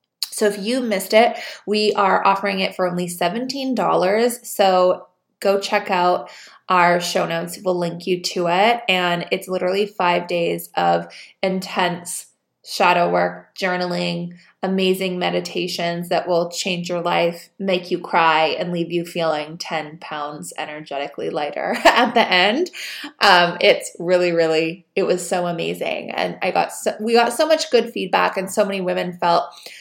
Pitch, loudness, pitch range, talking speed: 180 Hz, -19 LUFS, 170-195 Hz, 160 wpm